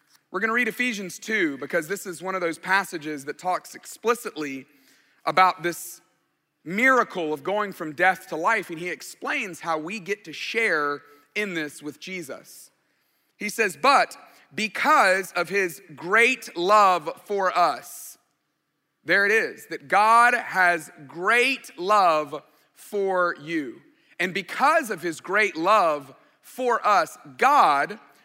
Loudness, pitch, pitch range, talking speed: -23 LUFS, 185 Hz, 160-215 Hz, 140 wpm